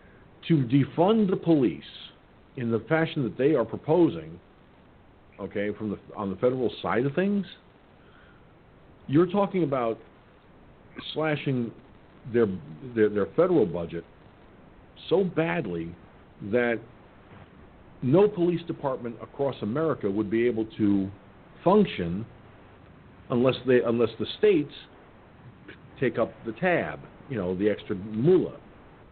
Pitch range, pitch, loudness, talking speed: 105-160 Hz, 120 Hz, -26 LUFS, 115 wpm